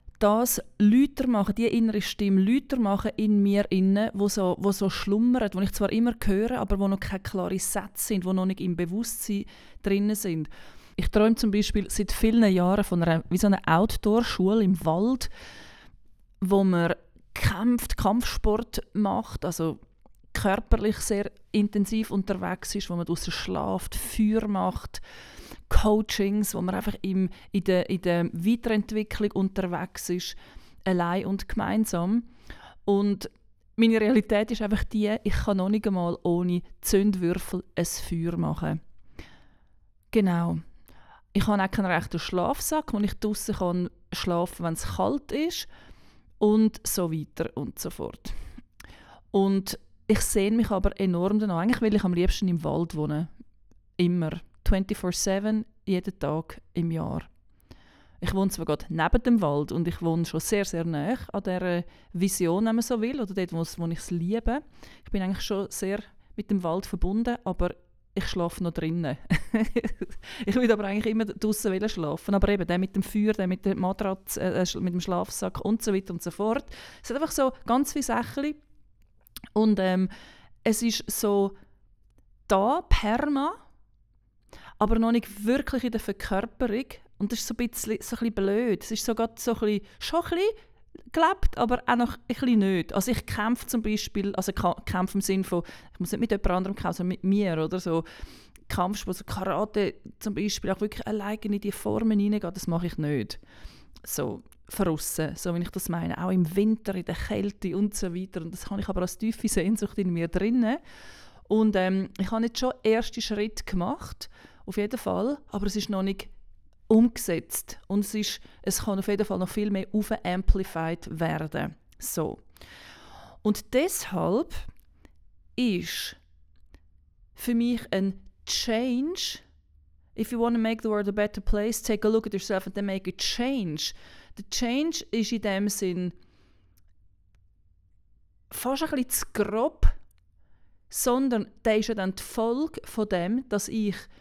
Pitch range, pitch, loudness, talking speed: 180-220 Hz, 200 Hz, -27 LUFS, 165 wpm